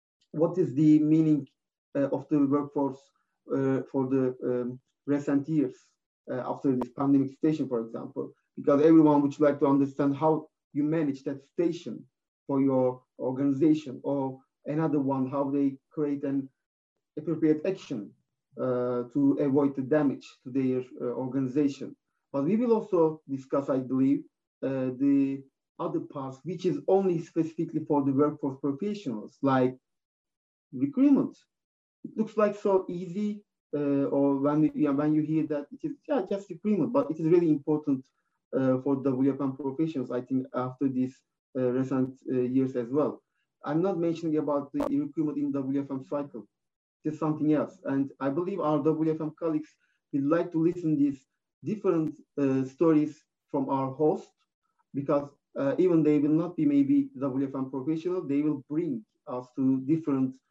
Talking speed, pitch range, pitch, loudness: 160 wpm, 135-165 Hz, 145 Hz, -28 LUFS